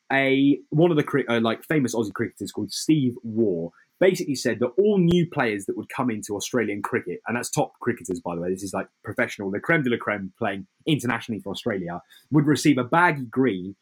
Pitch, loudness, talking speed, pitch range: 125 Hz, -24 LUFS, 215 wpm, 100-150 Hz